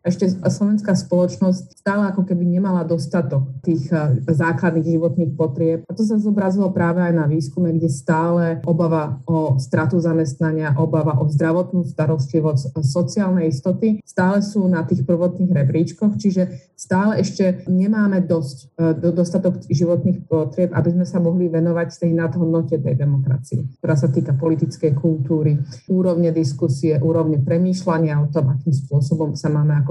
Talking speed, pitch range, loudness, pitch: 145 wpm, 155-180 Hz, -19 LUFS, 165 Hz